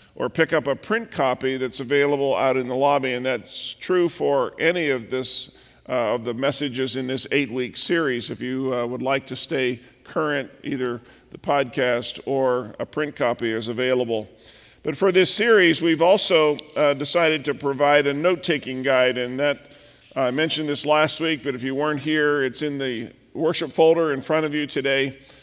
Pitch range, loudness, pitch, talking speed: 130-155 Hz, -22 LUFS, 140 Hz, 190 wpm